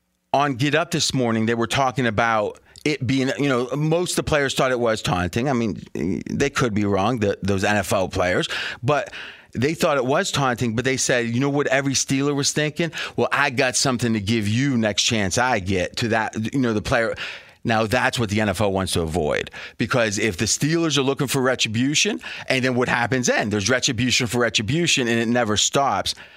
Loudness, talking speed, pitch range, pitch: -21 LUFS, 210 wpm, 115-140 Hz, 125 Hz